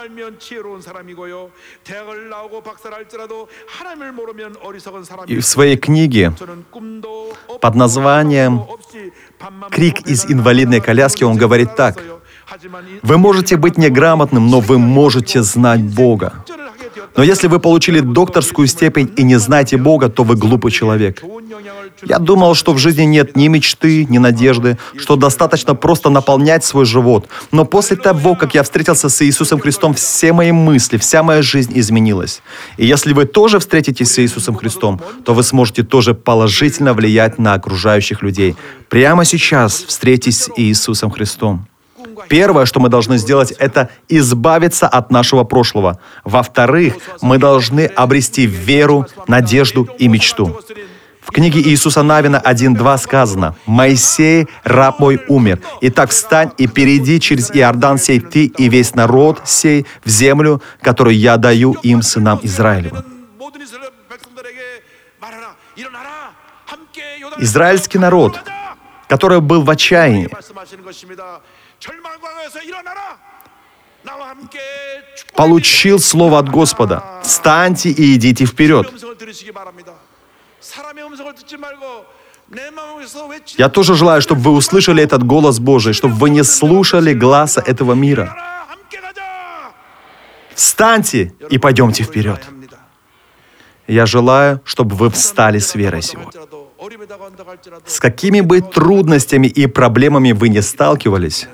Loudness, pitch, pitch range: -10 LUFS, 145 Hz, 125-190 Hz